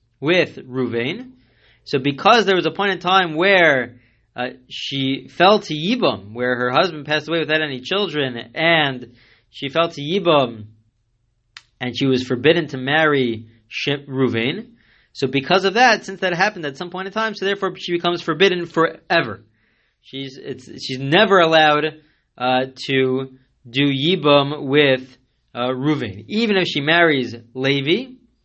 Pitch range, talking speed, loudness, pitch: 125-170 Hz, 150 wpm, -18 LUFS, 140 Hz